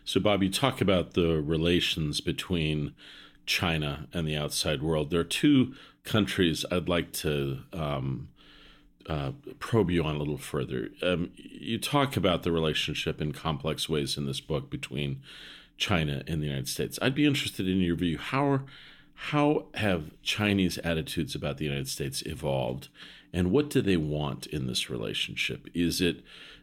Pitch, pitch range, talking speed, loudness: 85 Hz, 75-95 Hz, 165 wpm, -29 LUFS